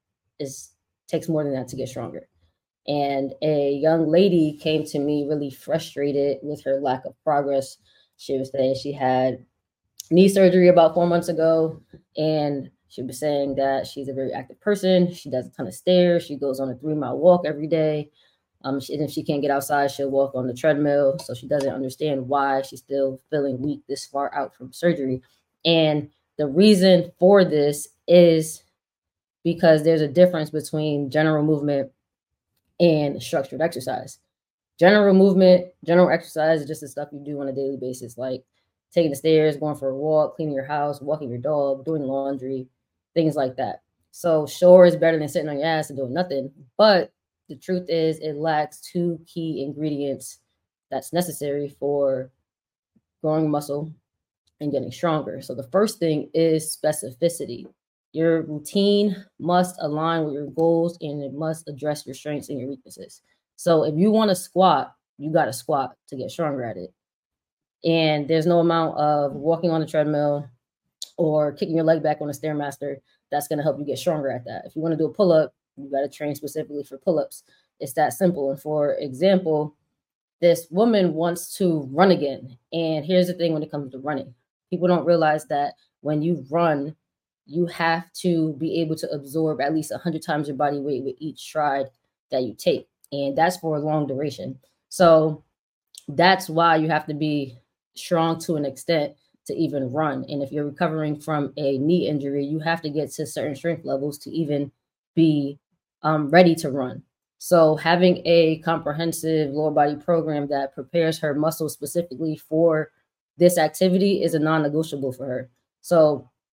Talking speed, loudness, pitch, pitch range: 185 wpm, -22 LUFS, 150 Hz, 140-165 Hz